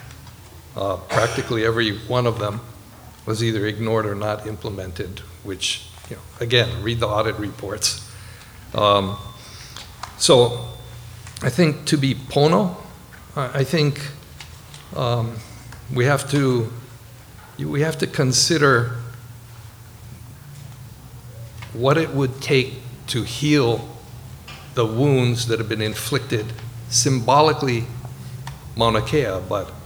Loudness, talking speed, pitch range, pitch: -21 LUFS, 105 wpm, 110-135 Hz, 120 Hz